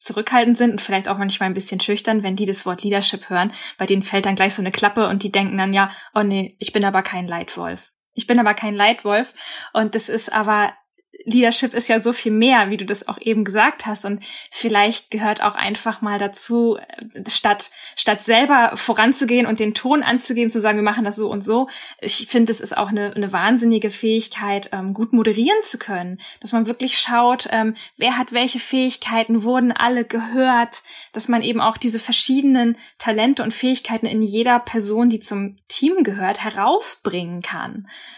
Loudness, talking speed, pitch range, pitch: -18 LUFS, 190 wpm, 205-240 Hz, 220 Hz